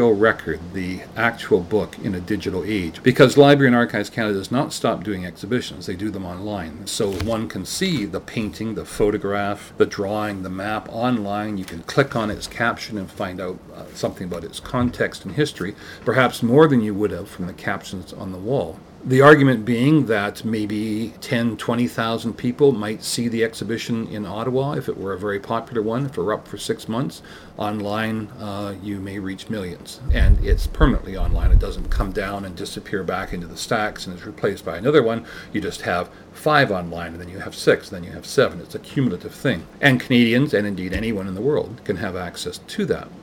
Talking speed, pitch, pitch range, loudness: 205 wpm, 105 Hz, 95-120 Hz, -21 LUFS